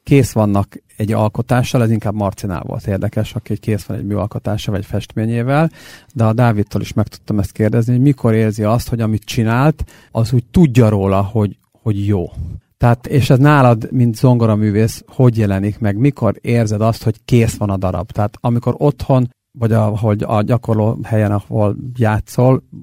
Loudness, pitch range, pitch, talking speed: -16 LUFS, 105-125 Hz, 110 Hz, 175 wpm